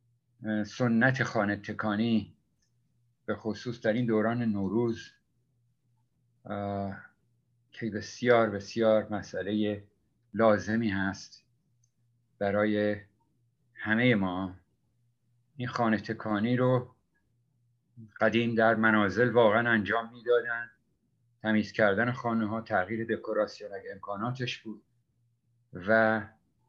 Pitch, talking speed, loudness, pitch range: 115 Hz, 85 wpm, -29 LUFS, 105-120 Hz